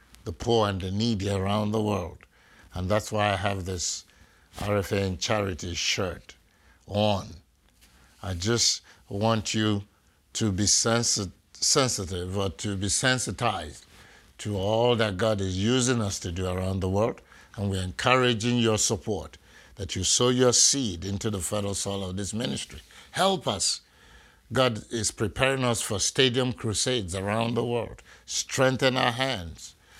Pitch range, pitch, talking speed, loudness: 95-115 Hz, 105 Hz, 150 wpm, -26 LUFS